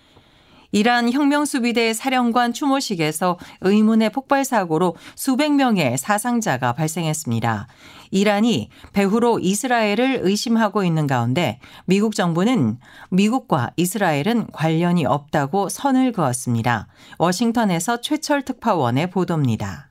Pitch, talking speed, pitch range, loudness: 200 Hz, 300 characters per minute, 160-240 Hz, -20 LUFS